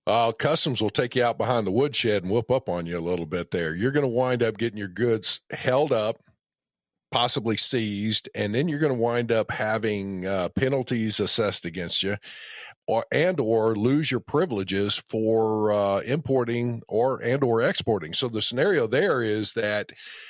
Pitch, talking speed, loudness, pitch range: 110 Hz, 185 wpm, -24 LUFS, 100-125 Hz